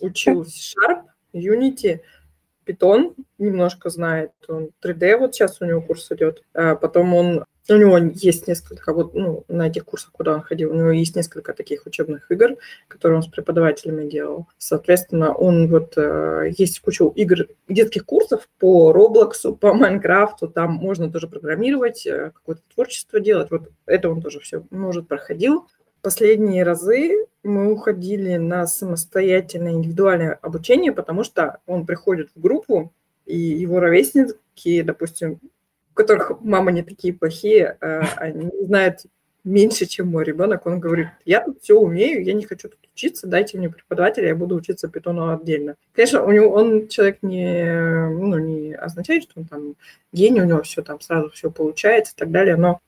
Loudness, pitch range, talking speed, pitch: -18 LUFS, 165-210 Hz, 160 wpm, 180 Hz